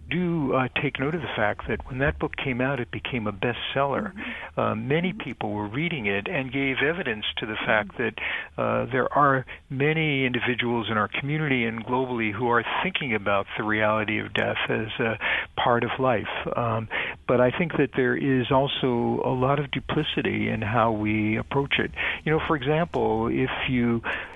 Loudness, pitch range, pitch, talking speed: -25 LUFS, 110-140 Hz, 125 Hz, 185 wpm